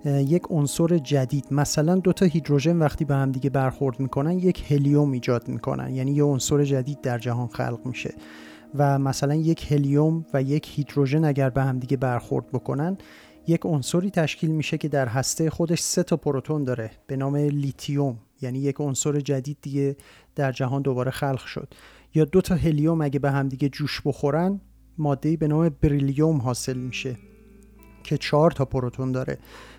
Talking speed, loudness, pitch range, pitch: 160 wpm, -24 LUFS, 135-155 Hz, 145 Hz